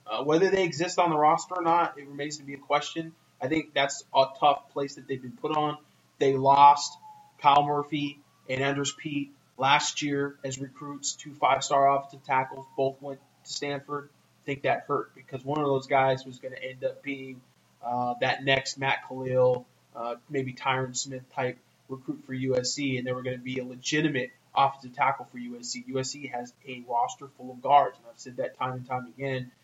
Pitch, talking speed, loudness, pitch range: 140 Hz, 205 wpm, -28 LUFS, 130-145 Hz